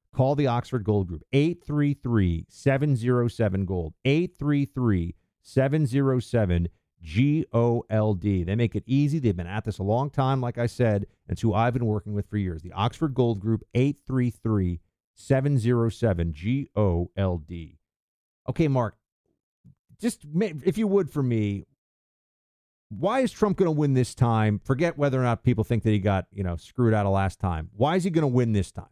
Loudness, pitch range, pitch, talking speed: -25 LUFS, 100-135 Hz, 115 Hz, 180 wpm